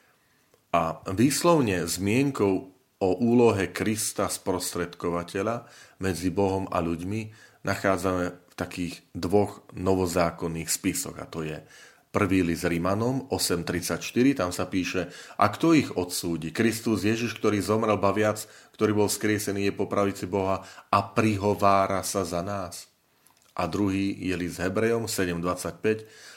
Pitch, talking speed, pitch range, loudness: 95 Hz, 125 wpm, 90-105 Hz, -26 LUFS